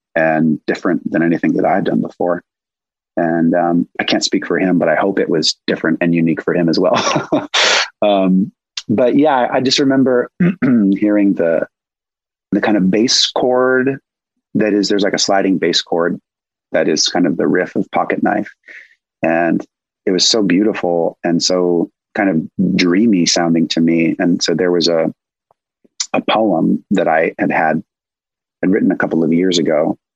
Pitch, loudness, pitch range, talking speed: 90 Hz, -15 LUFS, 85-125 Hz, 175 wpm